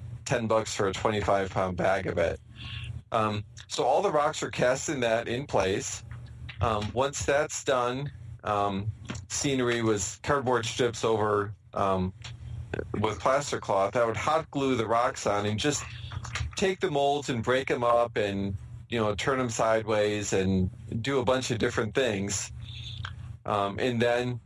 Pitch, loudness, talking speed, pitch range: 115 Hz, -28 LUFS, 160 wpm, 105-125 Hz